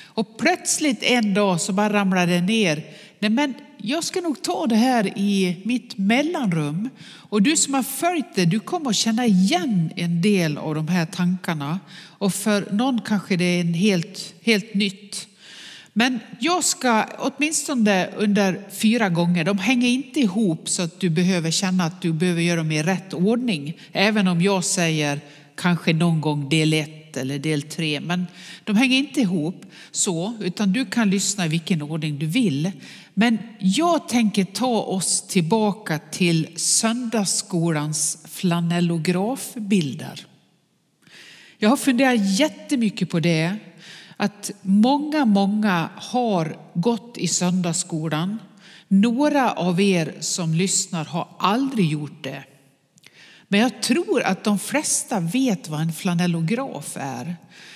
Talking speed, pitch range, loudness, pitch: 145 wpm, 170-225 Hz, -21 LUFS, 195 Hz